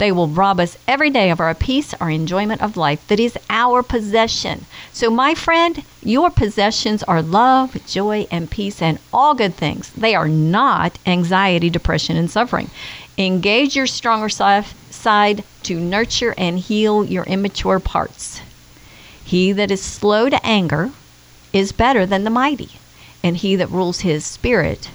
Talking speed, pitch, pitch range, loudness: 160 wpm, 200 Hz, 175-225 Hz, -17 LUFS